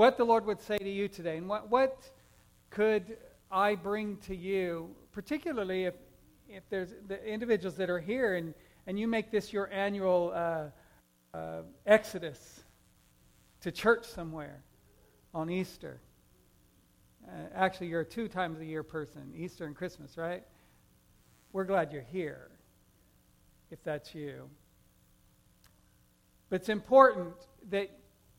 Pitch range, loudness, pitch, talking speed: 155-210 Hz, -33 LUFS, 185 Hz, 135 wpm